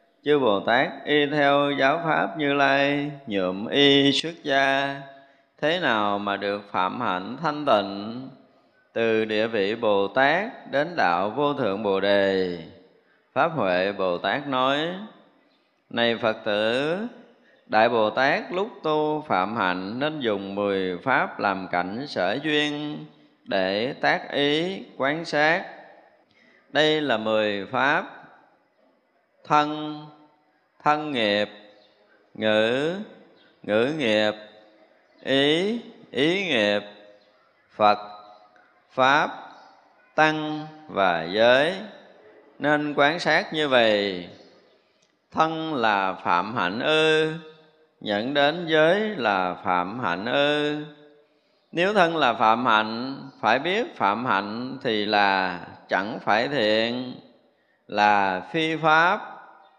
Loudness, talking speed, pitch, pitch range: -23 LUFS, 110 wpm, 135 Hz, 105-150 Hz